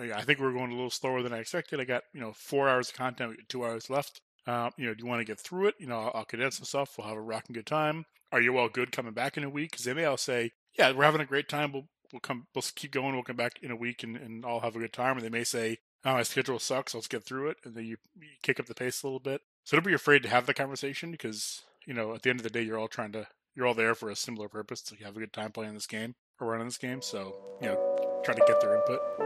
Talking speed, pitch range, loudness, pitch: 320 wpm, 115-140 Hz, -31 LUFS, 125 Hz